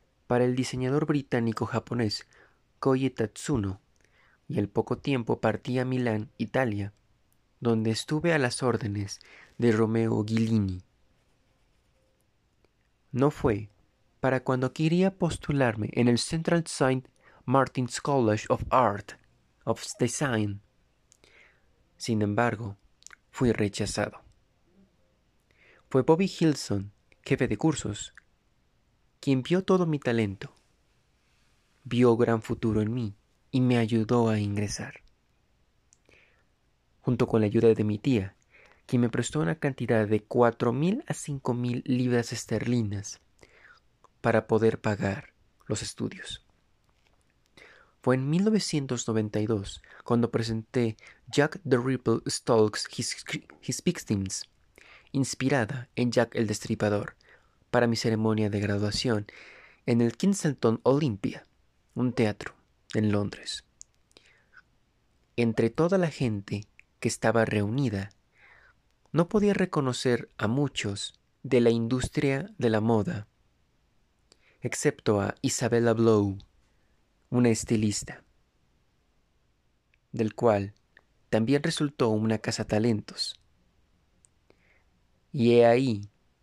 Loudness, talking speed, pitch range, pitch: -27 LUFS, 105 wpm, 110-130 Hz, 120 Hz